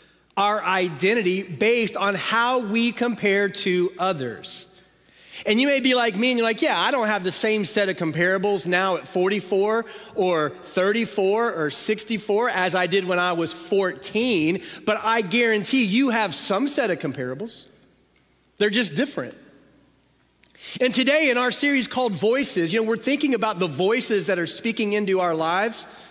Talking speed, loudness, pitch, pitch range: 170 wpm, -22 LUFS, 210 Hz, 185-235 Hz